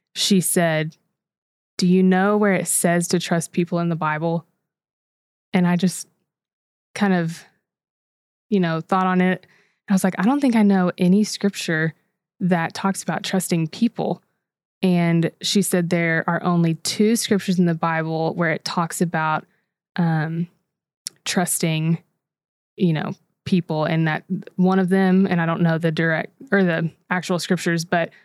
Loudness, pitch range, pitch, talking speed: -21 LUFS, 165-190 Hz, 180 Hz, 160 wpm